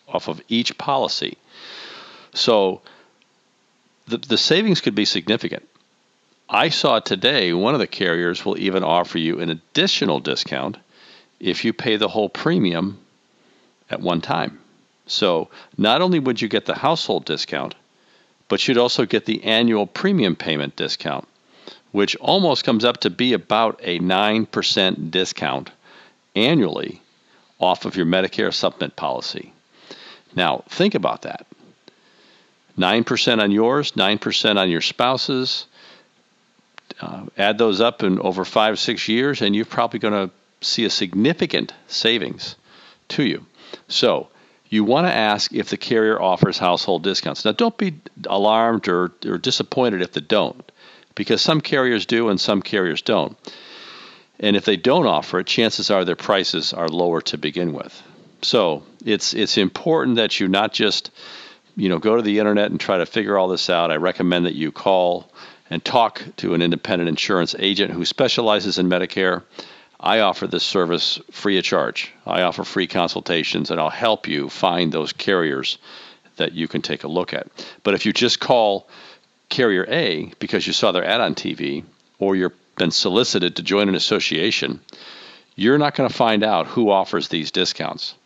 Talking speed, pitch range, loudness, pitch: 160 wpm, 90-115 Hz, -19 LUFS, 100 Hz